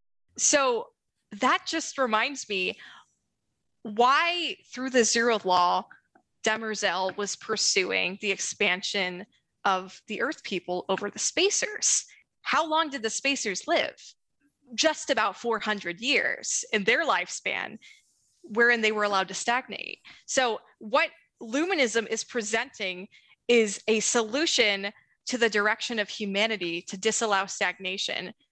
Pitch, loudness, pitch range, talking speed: 220 Hz, -26 LUFS, 200-260 Hz, 120 wpm